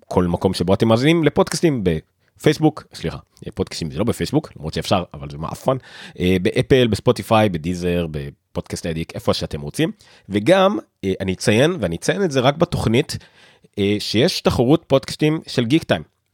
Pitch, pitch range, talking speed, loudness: 105 Hz, 90-135 Hz, 145 wpm, -19 LUFS